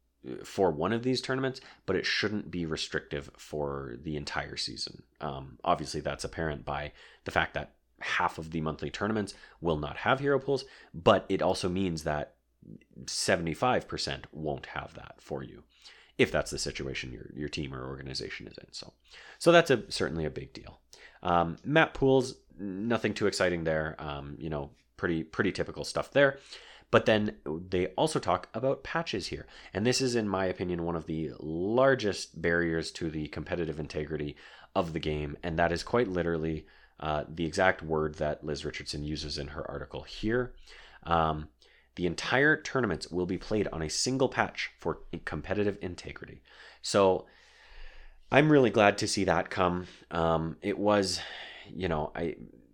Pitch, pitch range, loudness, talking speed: 85 Hz, 75-105 Hz, -30 LUFS, 170 wpm